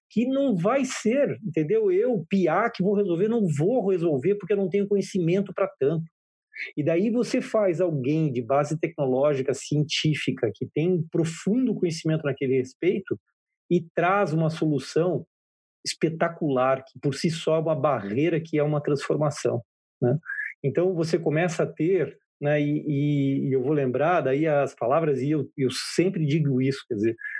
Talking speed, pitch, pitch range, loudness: 165 wpm, 160 Hz, 140-190 Hz, -25 LUFS